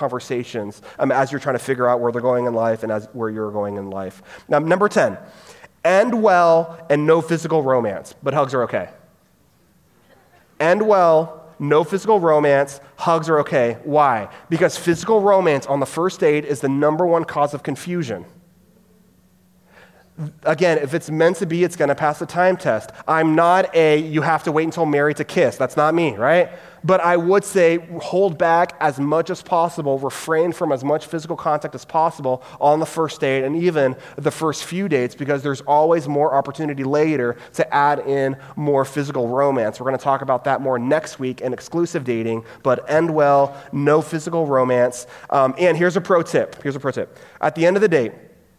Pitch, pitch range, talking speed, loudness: 150 Hz, 135-170 Hz, 195 wpm, -19 LUFS